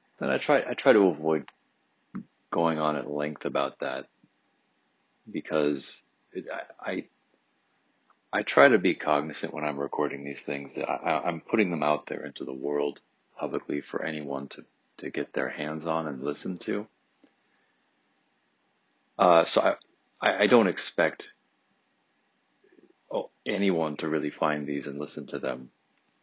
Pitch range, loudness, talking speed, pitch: 70-80 Hz, -28 LUFS, 145 wpm, 75 Hz